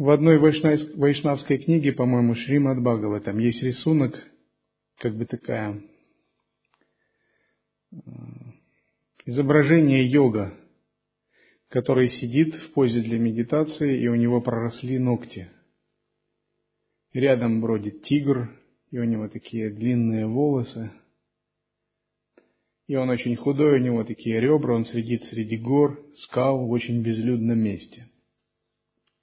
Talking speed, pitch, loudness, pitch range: 105 wpm, 125 Hz, -23 LUFS, 115-140 Hz